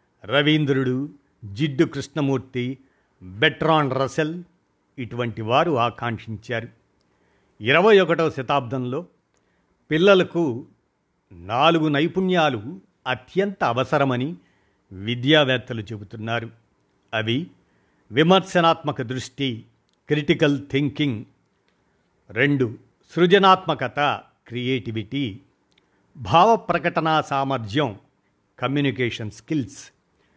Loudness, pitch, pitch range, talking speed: -21 LUFS, 135 Hz, 120-155 Hz, 60 wpm